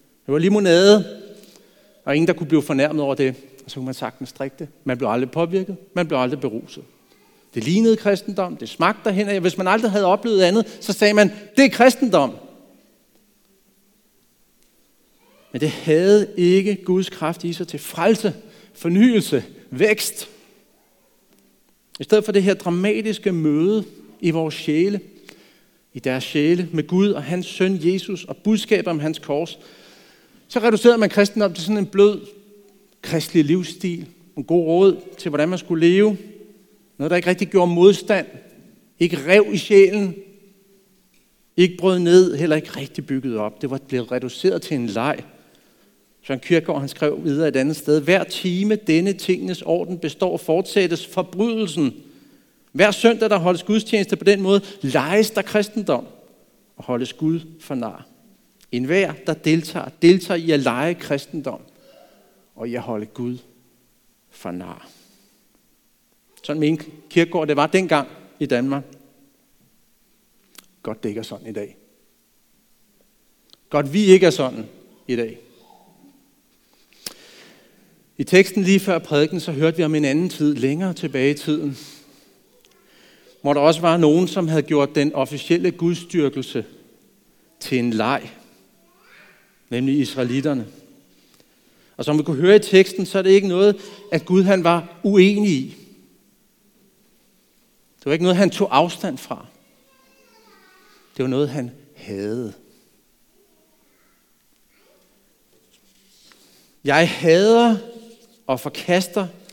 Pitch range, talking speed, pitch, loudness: 150-200 Hz, 140 wpm, 180 Hz, -19 LUFS